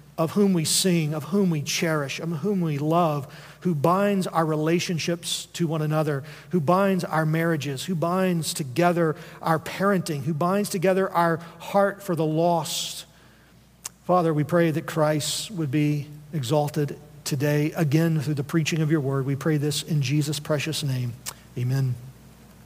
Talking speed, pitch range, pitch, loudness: 160 wpm, 150-175 Hz, 160 Hz, -24 LUFS